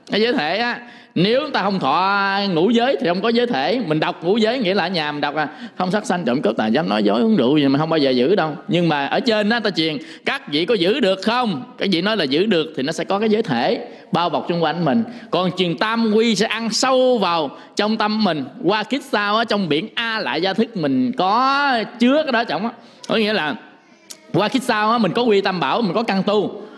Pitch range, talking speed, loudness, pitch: 180-235 Hz, 265 wpm, -19 LUFS, 210 Hz